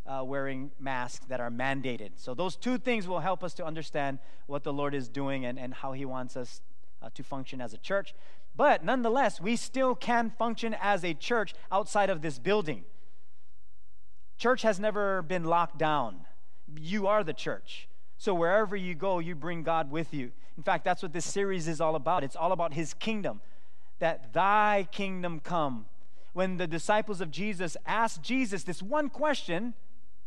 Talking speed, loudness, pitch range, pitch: 180 wpm, -31 LUFS, 135-200 Hz, 170 Hz